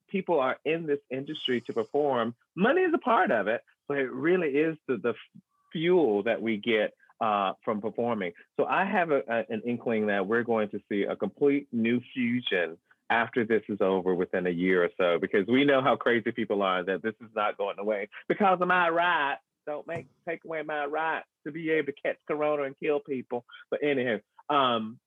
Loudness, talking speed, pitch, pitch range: -28 LUFS, 205 wpm, 135 Hz, 115-155 Hz